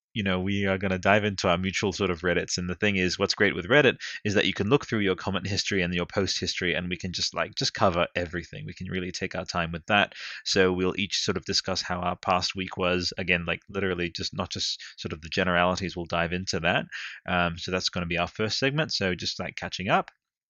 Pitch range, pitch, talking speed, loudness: 90-95 Hz, 90 Hz, 260 wpm, -26 LUFS